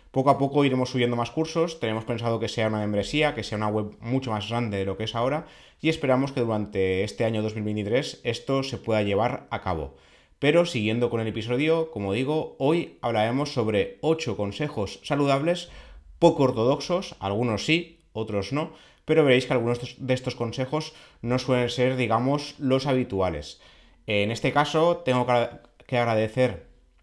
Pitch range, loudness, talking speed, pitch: 110-140 Hz, -25 LUFS, 170 wpm, 120 Hz